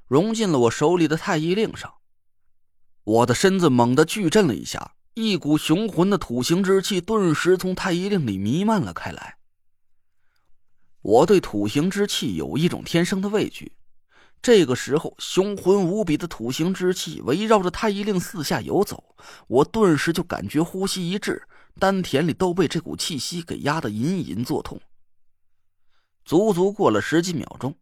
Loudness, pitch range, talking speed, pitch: -22 LUFS, 120-195 Hz, 245 characters per minute, 170 Hz